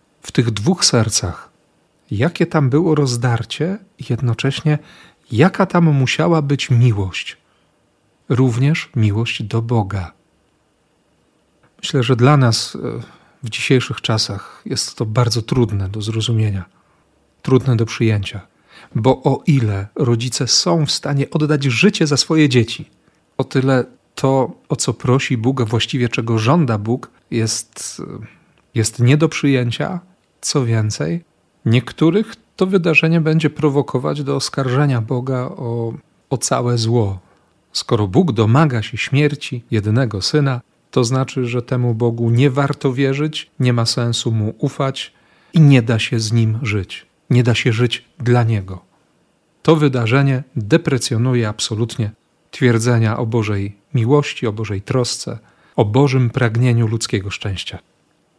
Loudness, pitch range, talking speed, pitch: -17 LUFS, 115-145 Hz, 130 wpm, 125 Hz